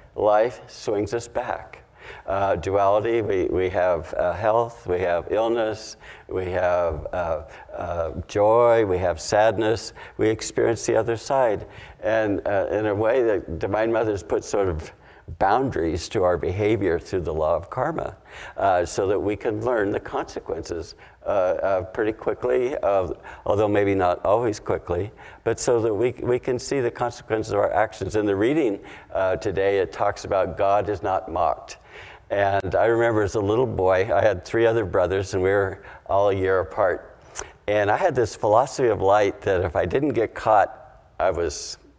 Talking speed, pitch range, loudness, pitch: 175 wpm, 95-115 Hz, -23 LUFS, 105 Hz